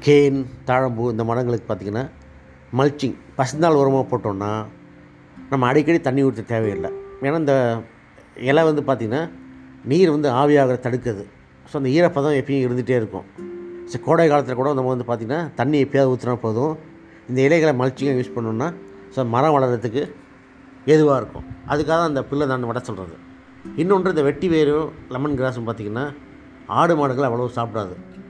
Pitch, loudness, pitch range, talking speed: 130 Hz, -20 LUFS, 115-145 Hz, 145 wpm